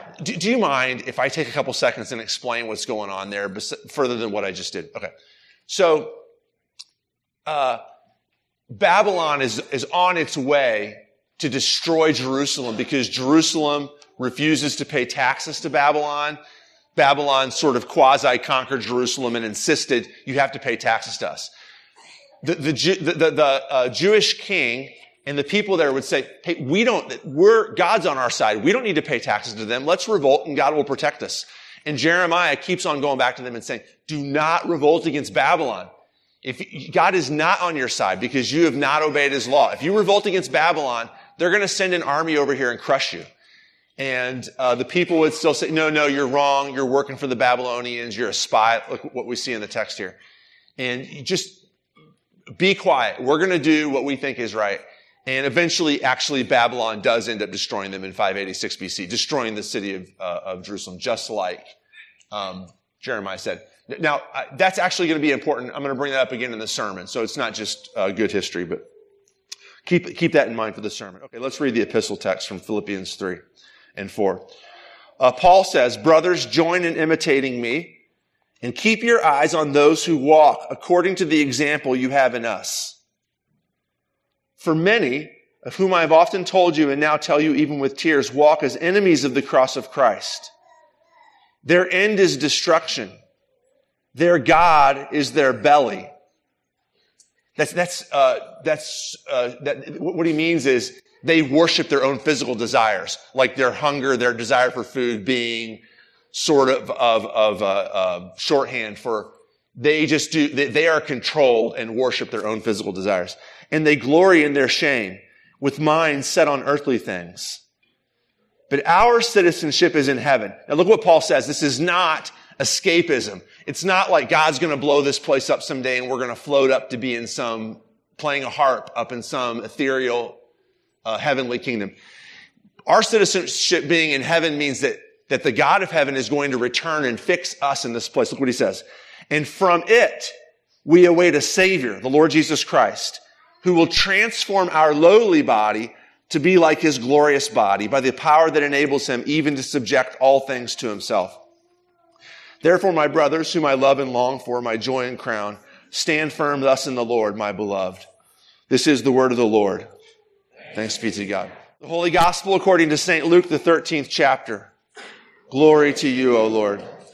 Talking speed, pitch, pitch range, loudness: 185 wpm, 145 Hz, 130-175 Hz, -19 LUFS